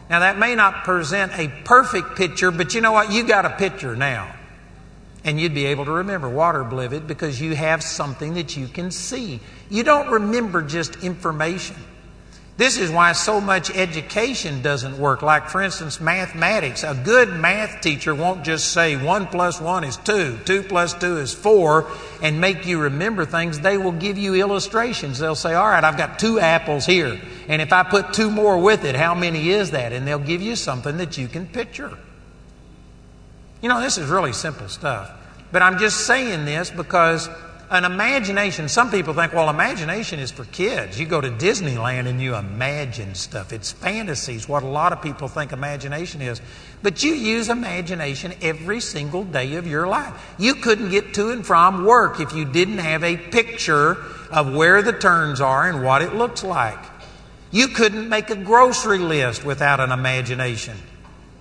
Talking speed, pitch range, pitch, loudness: 185 wpm, 145-200 Hz, 170 Hz, -19 LUFS